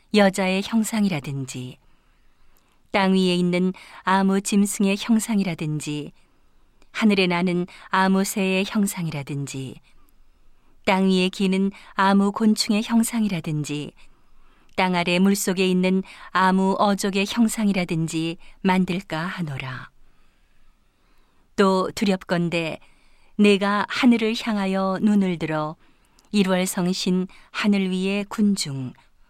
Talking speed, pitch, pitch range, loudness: 220 characters per minute, 190 Hz, 175-200 Hz, -22 LUFS